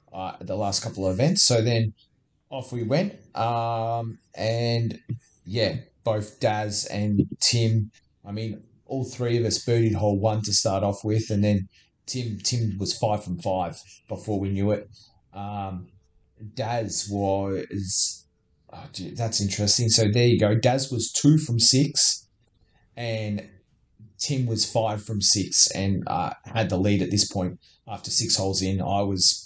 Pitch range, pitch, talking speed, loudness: 100-115 Hz, 105 Hz, 160 wpm, -24 LUFS